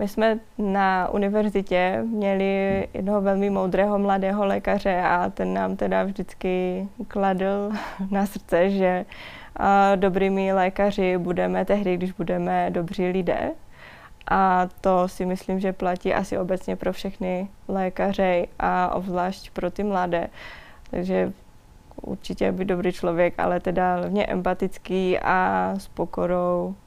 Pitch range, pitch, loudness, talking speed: 180-195 Hz, 185 Hz, -24 LUFS, 125 wpm